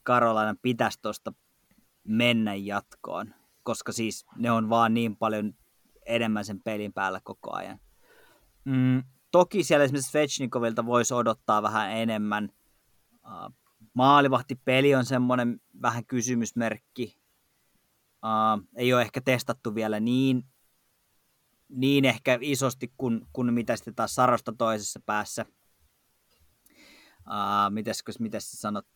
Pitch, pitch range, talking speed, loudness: 115 Hz, 110-125 Hz, 110 wpm, -27 LUFS